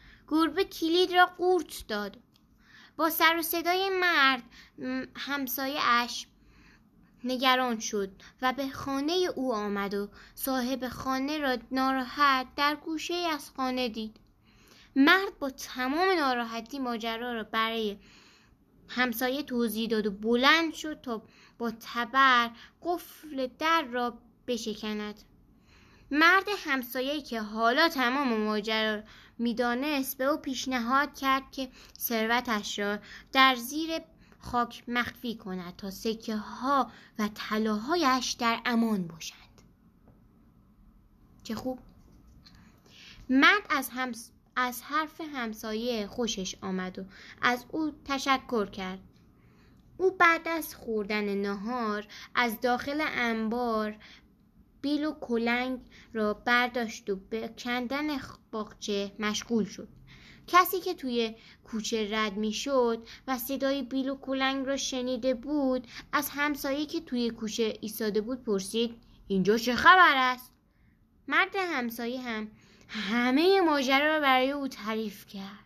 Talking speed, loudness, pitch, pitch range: 115 wpm, -28 LUFS, 250 Hz, 225-280 Hz